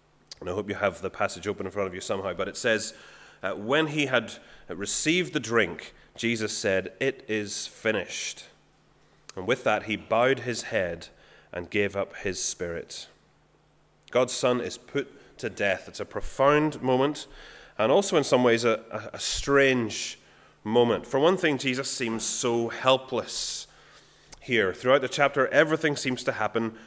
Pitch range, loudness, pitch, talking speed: 110-140 Hz, -26 LUFS, 125 Hz, 165 wpm